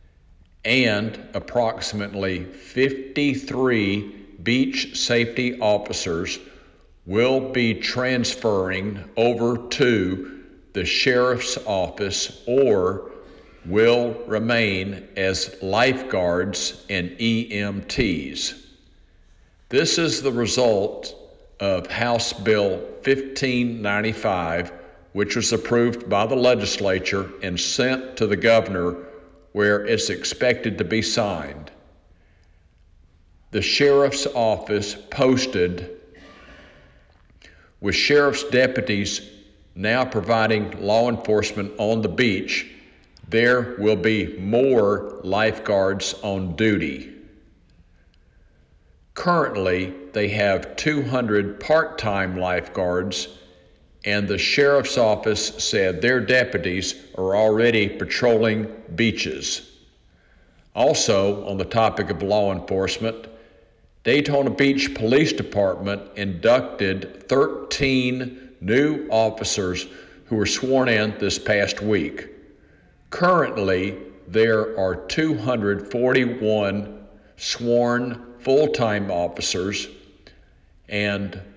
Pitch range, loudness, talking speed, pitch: 95-120 Hz, -21 LUFS, 85 wpm, 105 Hz